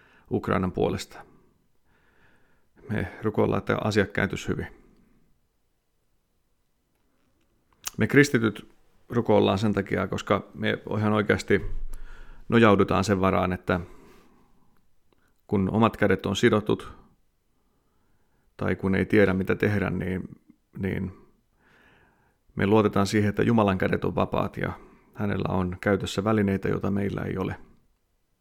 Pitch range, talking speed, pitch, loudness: 95-105 Hz, 105 wpm, 100 Hz, -25 LUFS